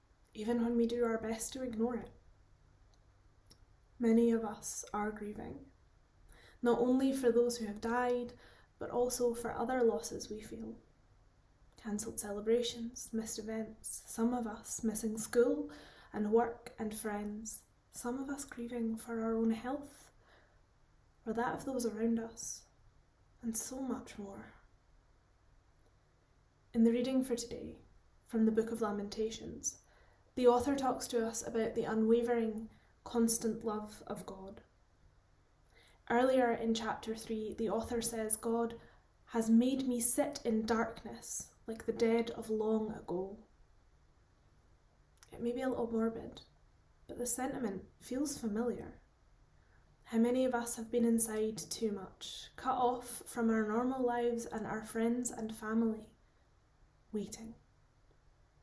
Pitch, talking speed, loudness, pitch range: 225 Hz, 135 wpm, -36 LUFS, 210-240 Hz